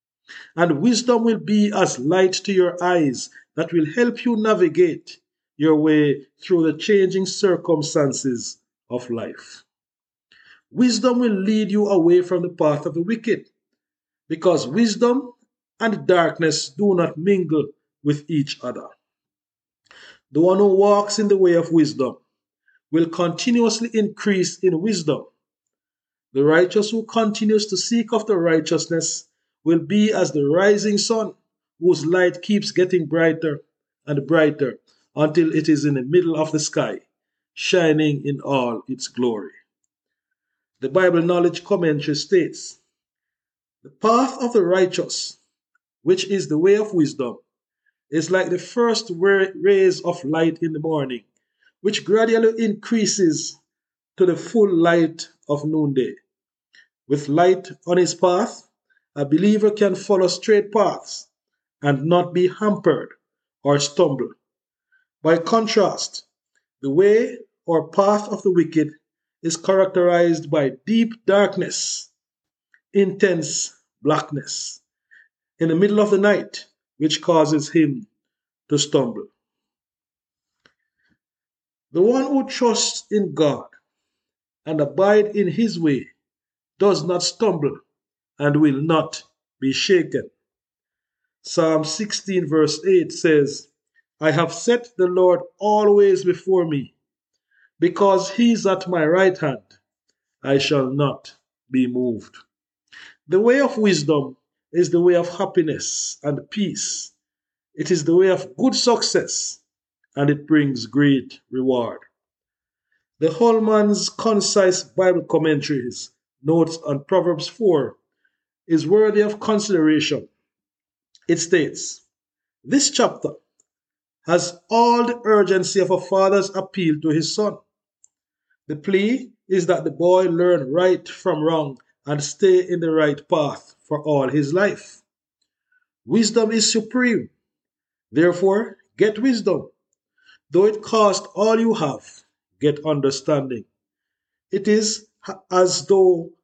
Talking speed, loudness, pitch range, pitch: 125 wpm, -19 LUFS, 155-210 Hz, 180 Hz